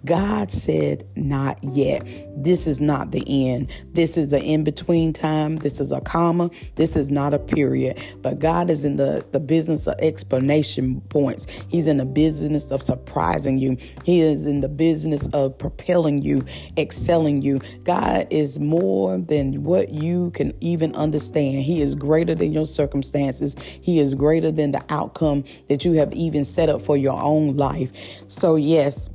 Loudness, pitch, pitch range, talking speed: -21 LUFS, 145 Hz, 135-160 Hz, 170 wpm